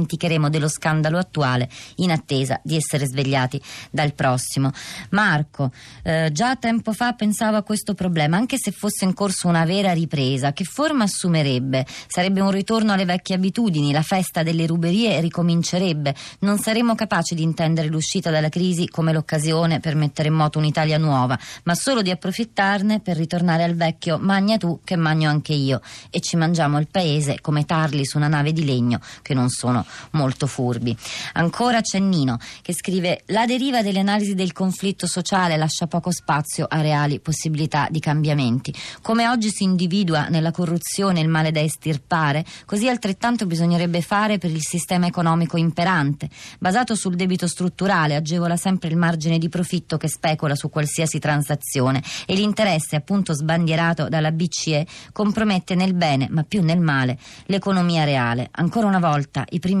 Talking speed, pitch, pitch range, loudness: 165 wpm, 165 Hz, 150-190 Hz, -21 LUFS